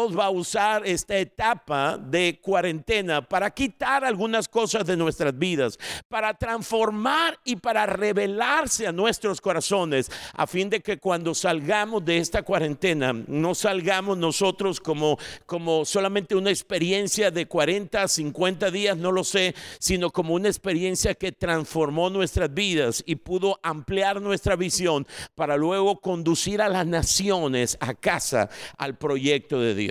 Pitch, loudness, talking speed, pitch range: 185 Hz, -24 LUFS, 140 wpm, 165-205 Hz